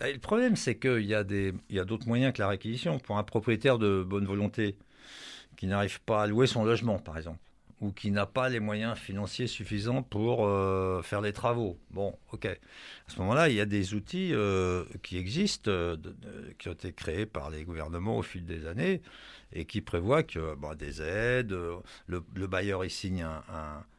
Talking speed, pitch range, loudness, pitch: 210 wpm, 90-115 Hz, -31 LUFS, 100 Hz